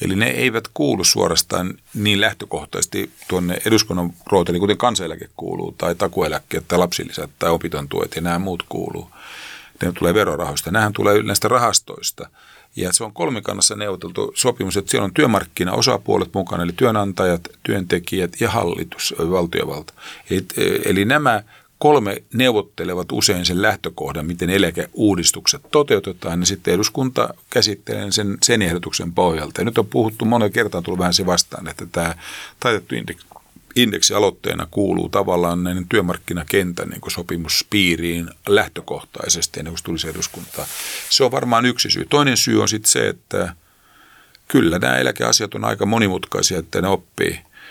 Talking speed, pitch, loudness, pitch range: 140 wpm, 95 Hz, -19 LUFS, 85-105 Hz